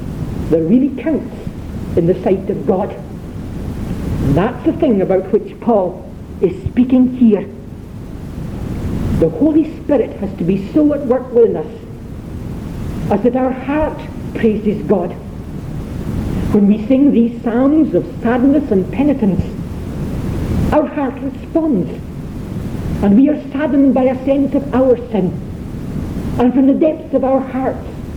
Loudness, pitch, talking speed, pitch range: -16 LUFS, 255 Hz, 135 wpm, 210-280 Hz